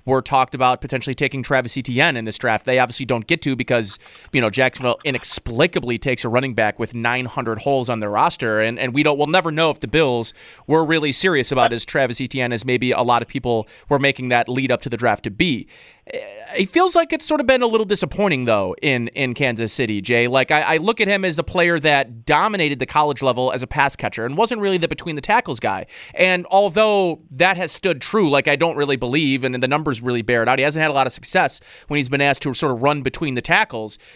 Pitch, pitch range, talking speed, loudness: 135 Hz, 125-160 Hz, 250 wpm, -19 LUFS